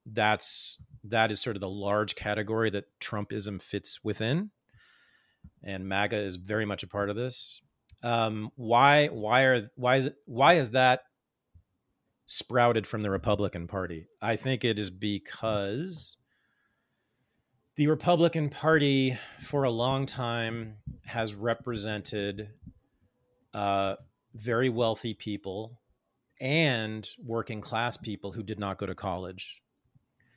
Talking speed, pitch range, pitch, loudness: 125 wpm, 100-125 Hz, 110 Hz, -29 LUFS